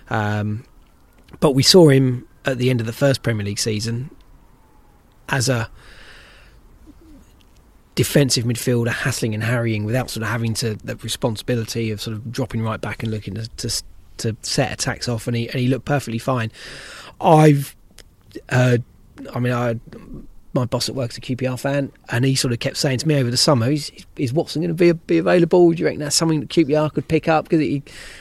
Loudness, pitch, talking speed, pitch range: -19 LUFS, 125 Hz, 195 wpm, 115-140 Hz